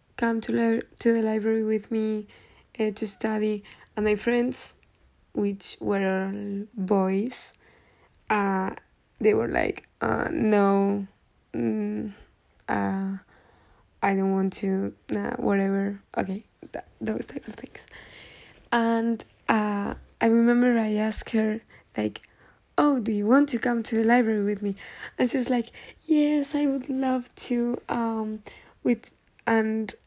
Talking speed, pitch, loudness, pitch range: 135 wpm, 220 Hz, -26 LUFS, 200-235 Hz